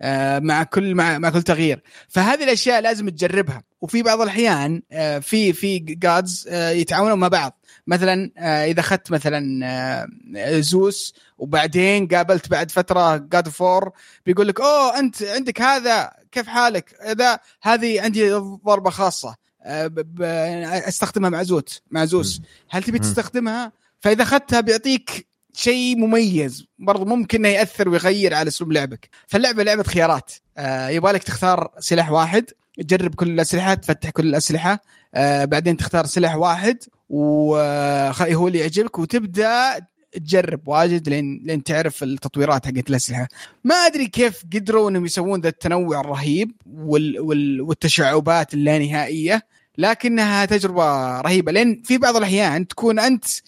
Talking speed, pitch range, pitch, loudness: 125 wpm, 155-215 Hz, 180 Hz, -19 LUFS